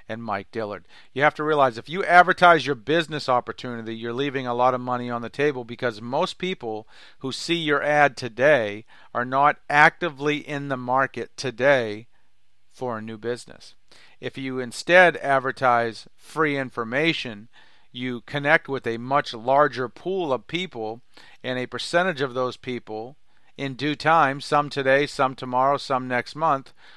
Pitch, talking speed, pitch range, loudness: 130 Hz, 160 wpm, 120-150 Hz, -23 LUFS